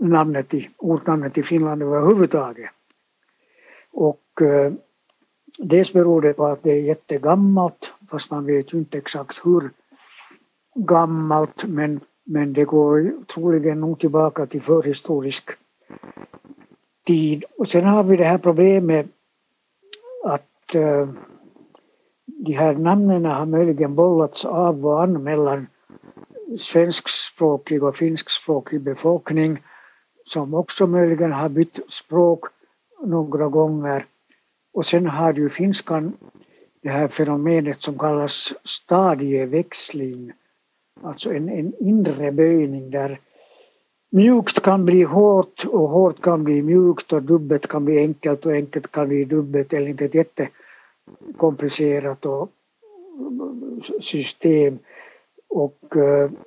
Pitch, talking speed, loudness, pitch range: 160 Hz, 115 wpm, -19 LUFS, 150-175 Hz